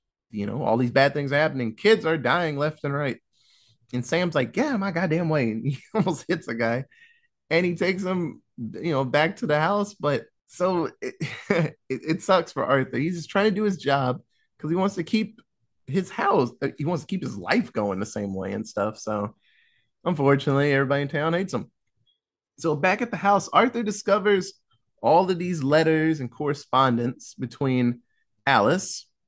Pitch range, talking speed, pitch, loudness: 130-185 Hz, 190 wpm, 155 Hz, -24 LUFS